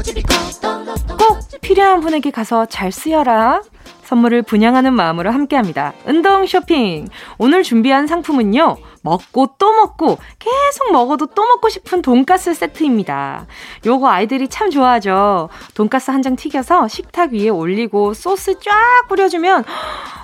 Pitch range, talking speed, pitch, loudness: 225-370 Hz, 290 characters per minute, 270 Hz, -14 LUFS